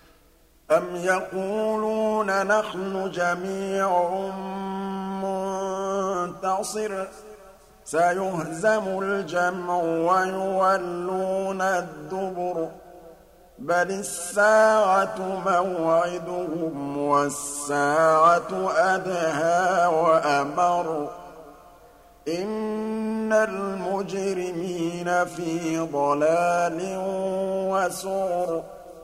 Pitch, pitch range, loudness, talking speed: 185 Hz, 175-195 Hz, -24 LUFS, 40 wpm